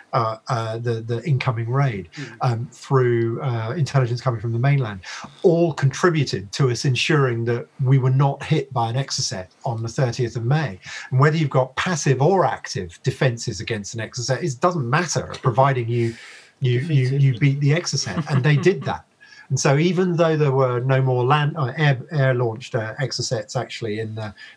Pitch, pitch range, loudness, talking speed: 130 Hz, 120-140 Hz, -21 LUFS, 185 wpm